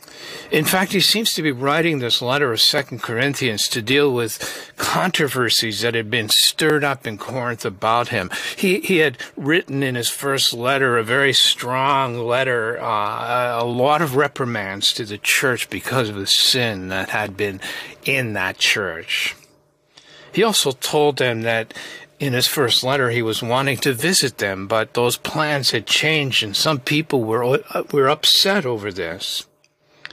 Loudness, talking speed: -18 LUFS, 165 wpm